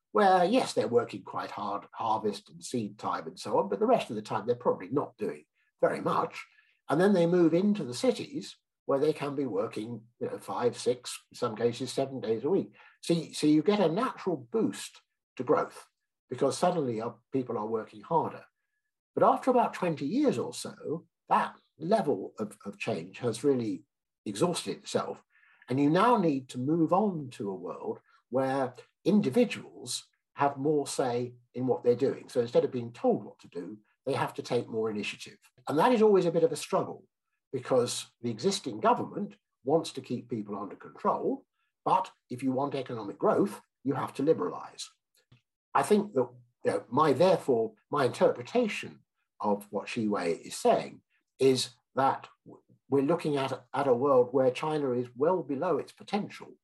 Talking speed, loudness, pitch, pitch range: 180 wpm, -30 LUFS, 150 Hz, 125-205 Hz